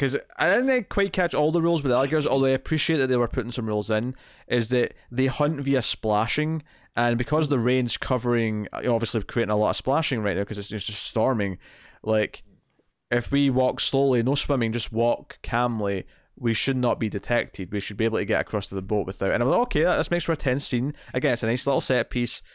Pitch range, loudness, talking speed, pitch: 110-135 Hz, -24 LUFS, 235 wpm, 120 Hz